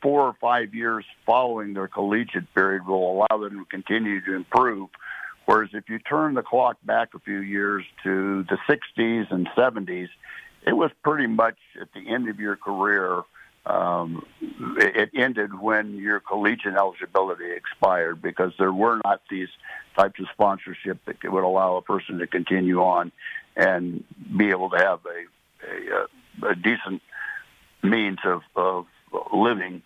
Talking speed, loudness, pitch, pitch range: 155 wpm, -24 LUFS, 105 Hz, 95-120 Hz